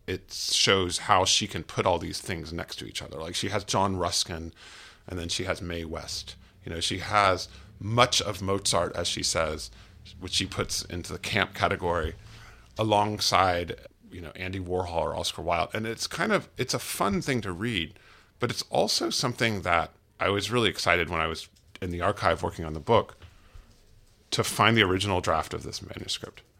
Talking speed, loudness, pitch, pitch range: 195 wpm, -27 LUFS, 95 Hz, 85-105 Hz